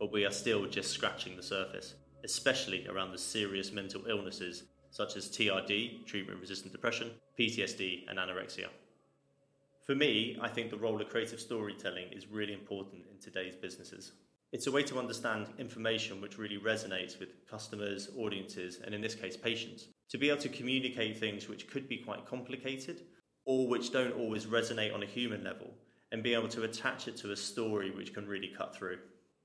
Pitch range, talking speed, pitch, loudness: 95-120 Hz, 180 wpm, 110 Hz, -37 LUFS